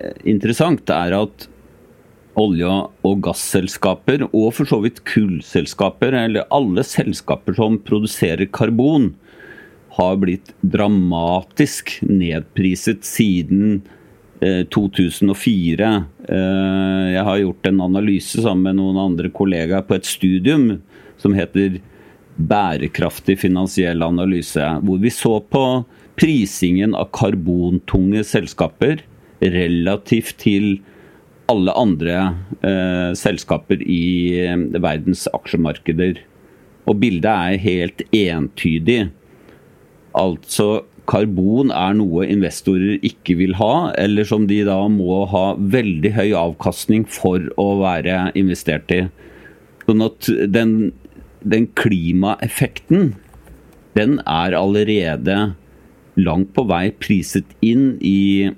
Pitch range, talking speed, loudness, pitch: 90-105 Hz, 100 wpm, -17 LUFS, 95 Hz